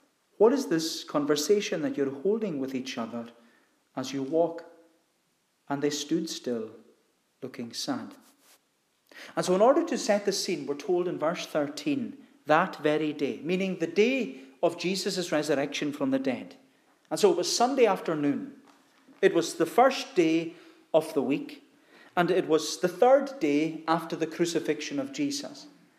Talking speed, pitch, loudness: 160 wpm, 175 Hz, -28 LUFS